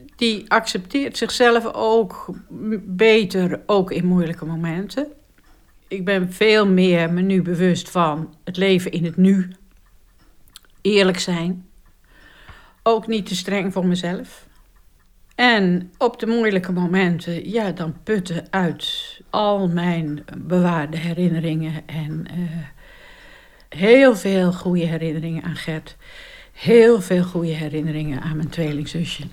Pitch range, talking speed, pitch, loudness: 165-215 Hz, 120 wpm, 180 Hz, -19 LUFS